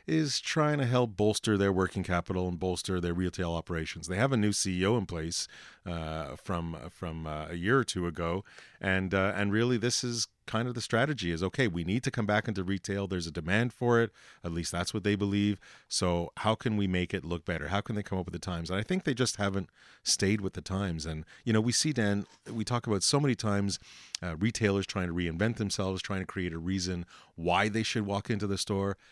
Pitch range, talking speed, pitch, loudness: 90-110 Hz, 235 wpm, 100 Hz, -31 LUFS